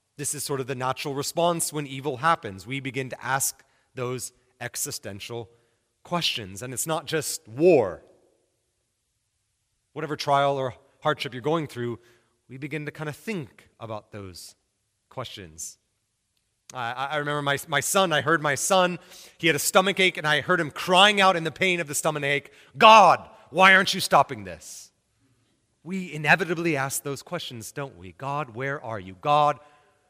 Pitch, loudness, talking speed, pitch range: 140 Hz, -23 LUFS, 165 wpm, 120-160 Hz